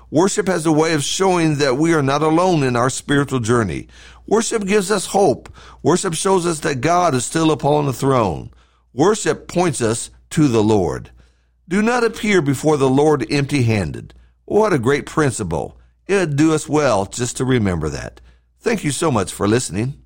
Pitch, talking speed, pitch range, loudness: 145 Hz, 185 wpm, 115-170 Hz, -17 LUFS